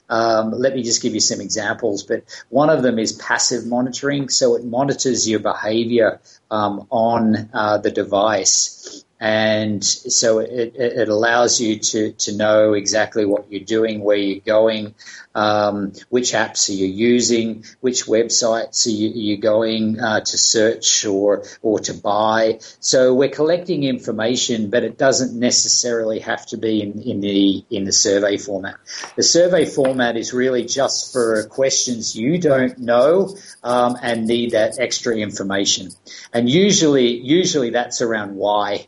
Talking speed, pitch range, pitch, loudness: 155 wpm, 105-125 Hz, 115 Hz, -17 LUFS